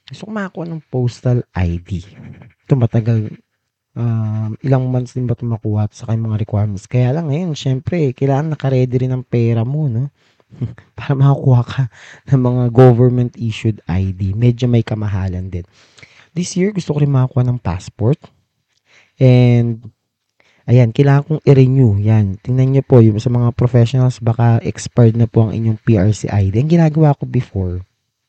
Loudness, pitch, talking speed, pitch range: -15 LUFS, 120 Hz, 155 wpm, 110-135 Hz